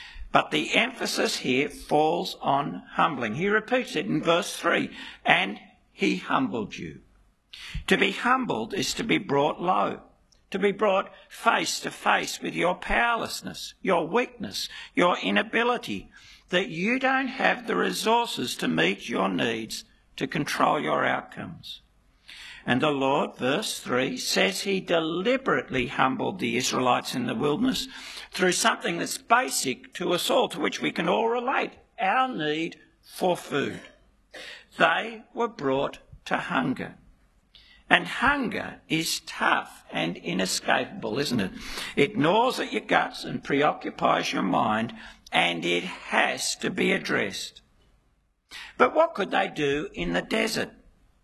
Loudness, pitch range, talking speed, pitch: -26 LUFS, 155-245 Hz, 140 wpm, 200 Hz